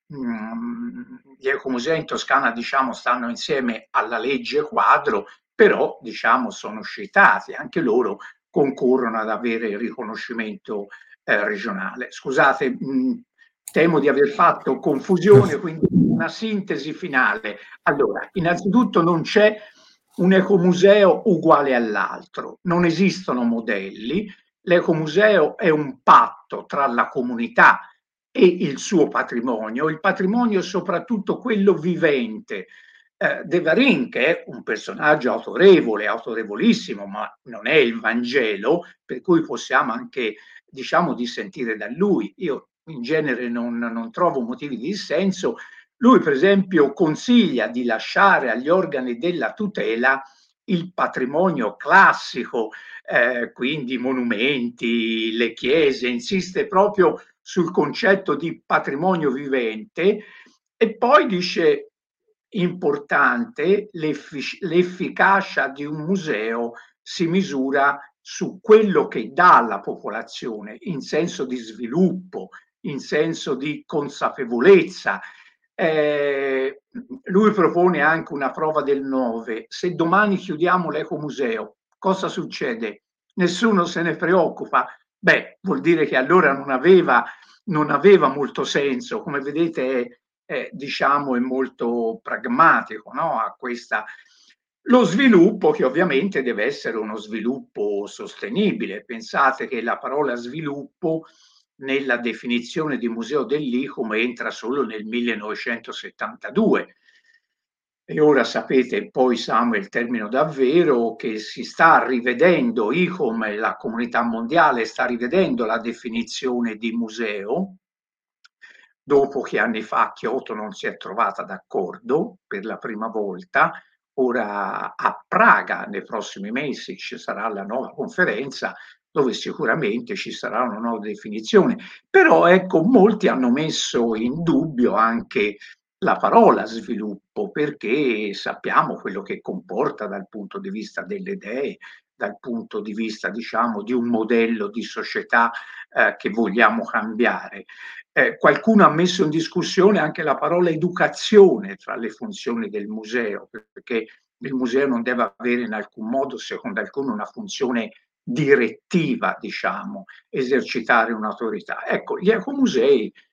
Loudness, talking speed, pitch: -20 LUFS, 120 wpm, 165 Hz